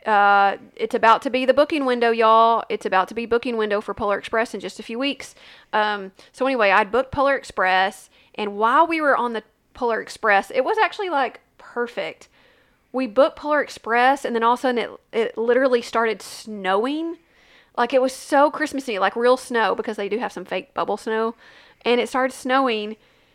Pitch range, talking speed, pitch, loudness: 215-260 Hz, 200 wpm, 235 Hz, -21 LUFS